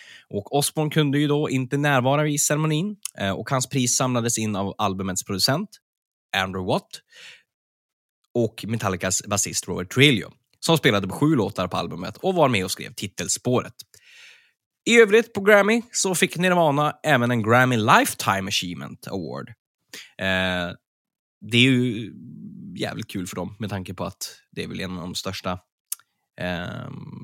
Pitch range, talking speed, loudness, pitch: 95-150 Hz, 155 wpm, -22 LUFS, 125 Hz